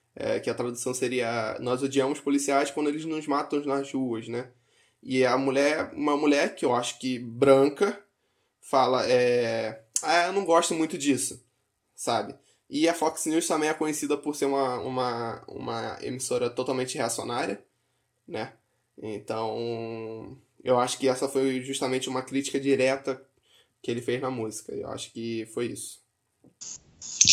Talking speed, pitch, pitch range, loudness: 155 wpm, 130 Hz, 120-140 Hz, -27 LUFS